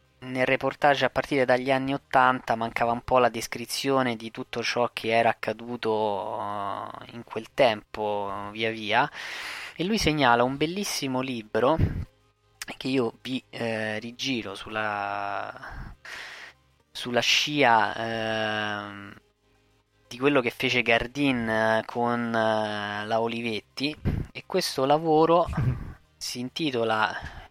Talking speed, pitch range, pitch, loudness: 115 wpm, 105-130 Hz, 115 Hz, -26 LUFS